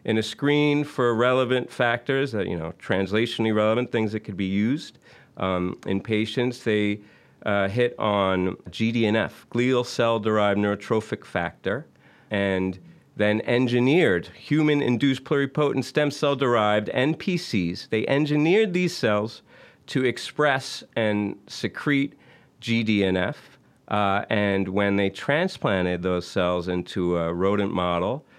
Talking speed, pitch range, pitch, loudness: 120 wpm, 100-130 Hz, 110 Hz, -24 LUFS